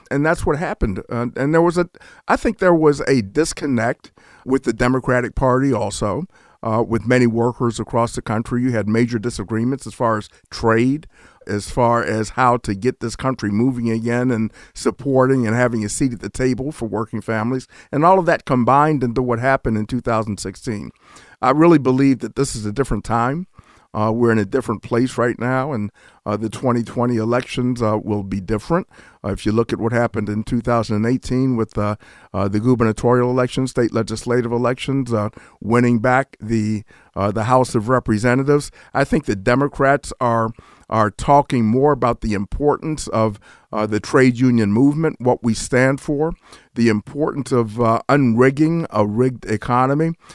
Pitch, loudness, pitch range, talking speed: 120 Hz, -19 LUFS, 110-130 Hz, 175 wpm